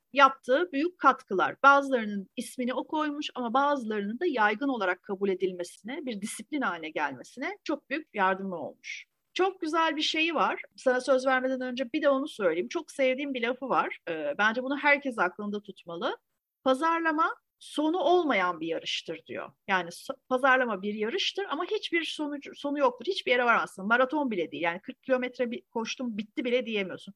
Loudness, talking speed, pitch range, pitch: -28 LUFS, 165 wpm, 215-300 Hz, 265 Hz